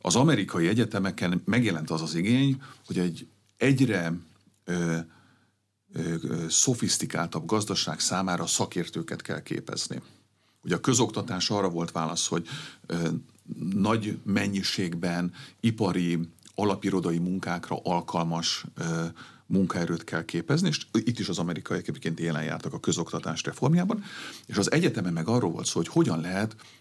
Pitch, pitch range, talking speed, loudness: 90 Hz, 85-105 Hz, 130 wpm, -28 LUFS